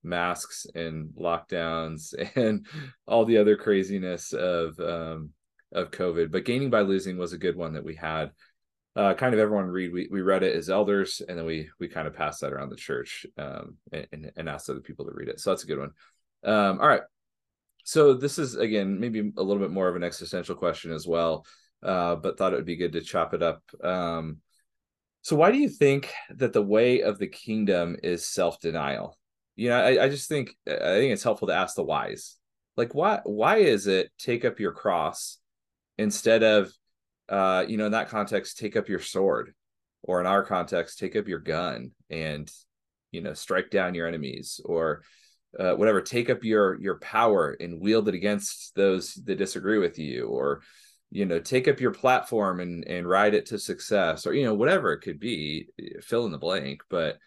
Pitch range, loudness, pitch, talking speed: 85-105 Hz, -26 LUFS, 95 Hz, 205 wpm